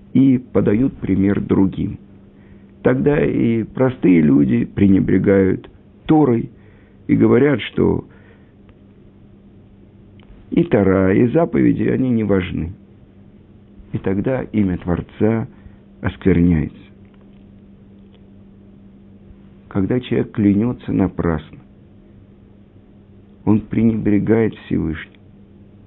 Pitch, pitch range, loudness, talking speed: 100 Hz, 100-105 Hz, -17 LUFS, 75 wpm